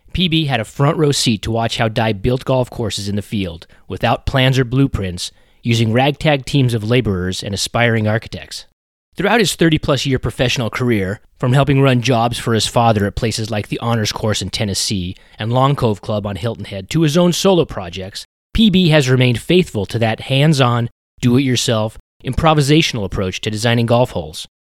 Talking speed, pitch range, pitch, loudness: 190 wpm, 105-135 Hz, 115 Hz, -16 LUFS